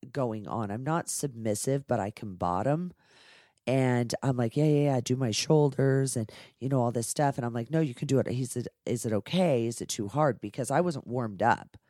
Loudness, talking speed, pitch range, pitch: -29 LUFS, 245 wpm, 115-145 Hz, 125 Hz